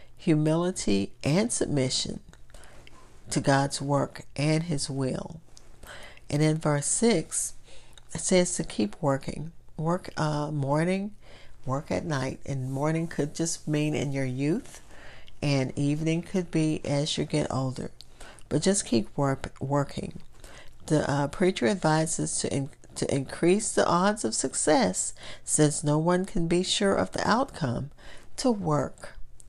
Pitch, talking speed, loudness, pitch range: 150 Hz, 140 wpm, -27 LUFS, 135-170 Hz